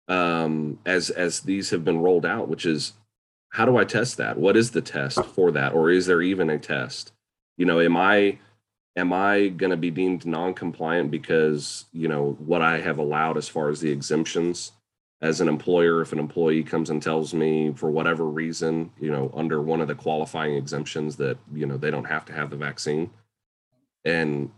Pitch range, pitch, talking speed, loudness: 75-90 Hz, 80 Hz, 205 wpm, -24 LUFS